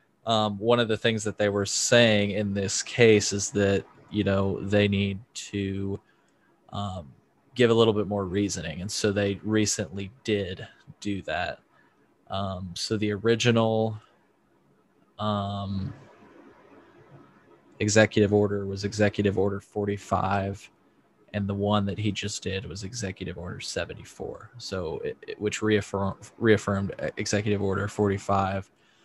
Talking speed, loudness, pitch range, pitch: 130 wpm, -26 LUFS, 100-110 Hz, 100 Hz